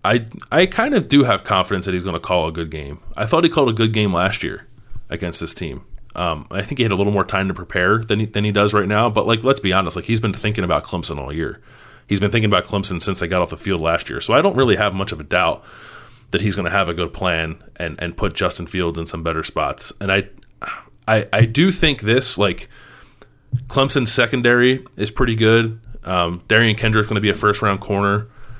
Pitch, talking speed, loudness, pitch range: 100 Hz, 255 wpm, -18 LUFS, 90-115 Hz